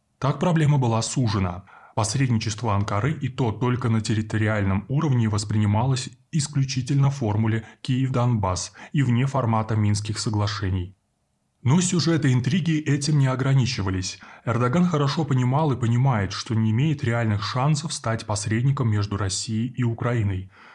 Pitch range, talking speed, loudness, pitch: 105-135 Hz, 125 wpm, -23 LUFS, 120 Hz